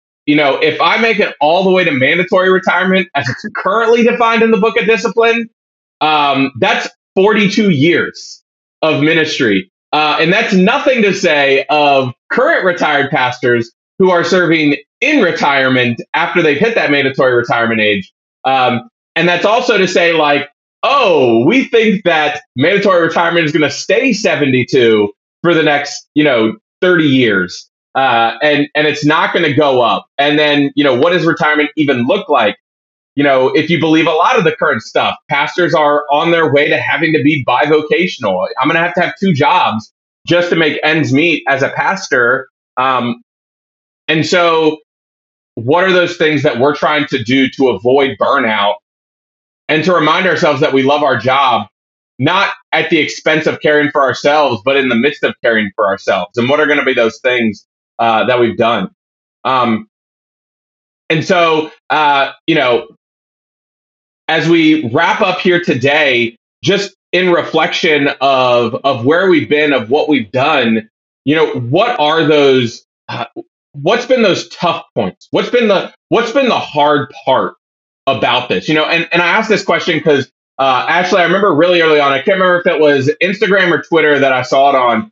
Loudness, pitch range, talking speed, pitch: -12 LUFS, 135-180 Hz, 180 wpm, 150 Hz